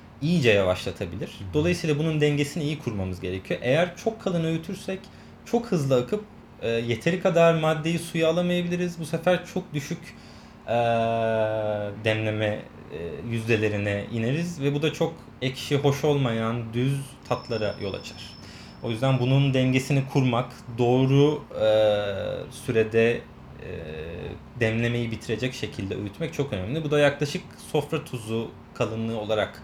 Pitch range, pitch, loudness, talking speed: 110-160 Hz, 130 Hz, -26 LUFS, 130 wpm